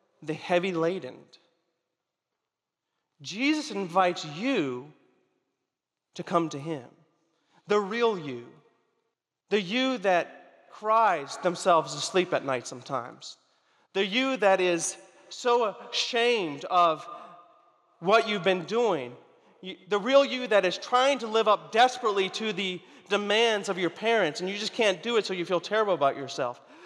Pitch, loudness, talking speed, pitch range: 190 Hz, -26 LUFS, 135 wpm, 170-220 Hz